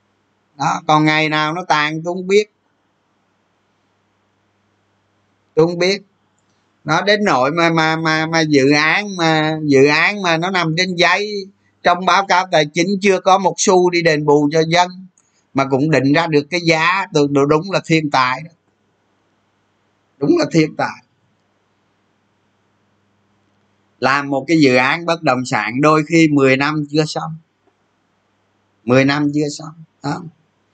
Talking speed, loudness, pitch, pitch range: 150 wpm, -15 LUFS, 145 Hz, 105-165 Hz